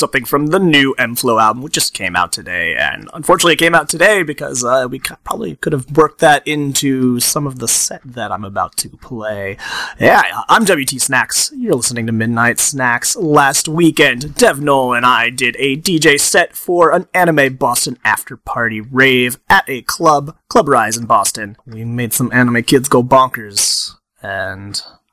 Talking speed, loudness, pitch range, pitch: 190 wpm, -13 LUFS, 115-145 Hz, 130 Hz